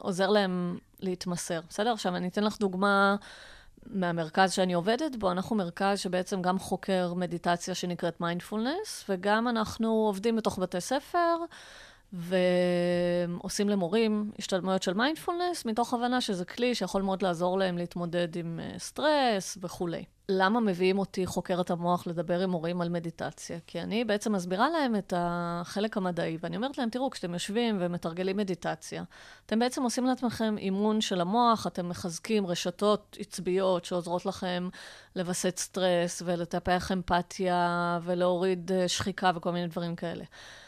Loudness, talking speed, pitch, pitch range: -30 LUFS, 135 wpm, 185 Hz, 175-210 Hz